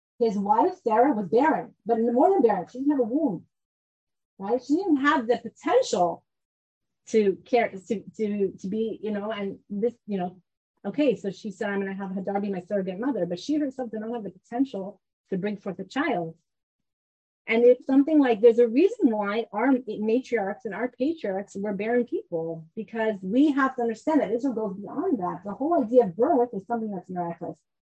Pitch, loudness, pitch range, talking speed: 220 Hz, -25 LUFS, 195-255 Hz, 200 wpm